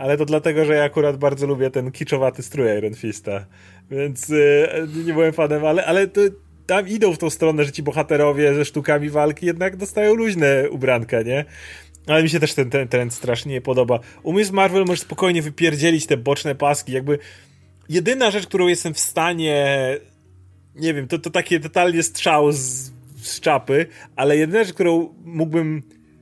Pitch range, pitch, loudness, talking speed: 130-165 Hz, 150 Hz, -19 LUFS, 180 wpm